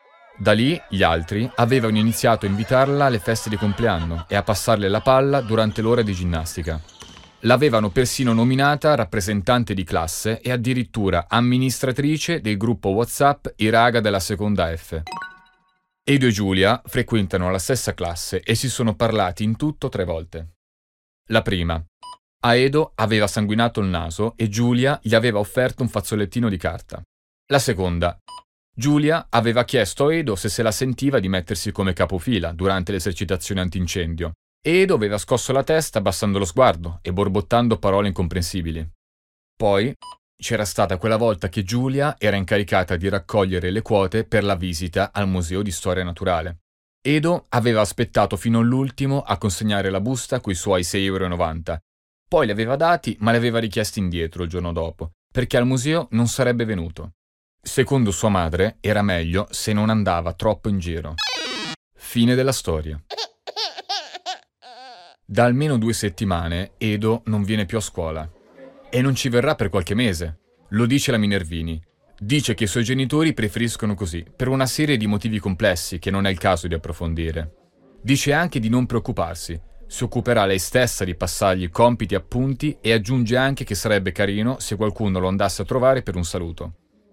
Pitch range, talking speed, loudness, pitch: 95-125 Hz, 160 wpm, -21 LUFS, 105 Hz